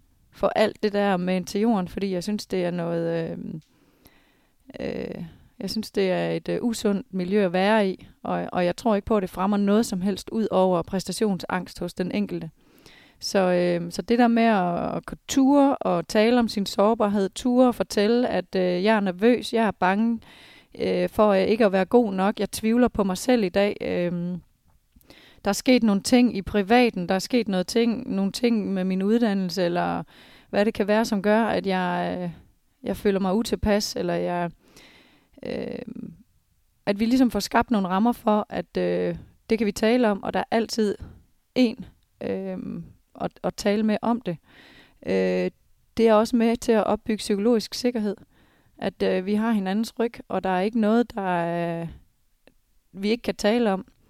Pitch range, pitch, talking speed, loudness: 185-225 Hz, 205 Hz, 195 wpm, -24 LUFS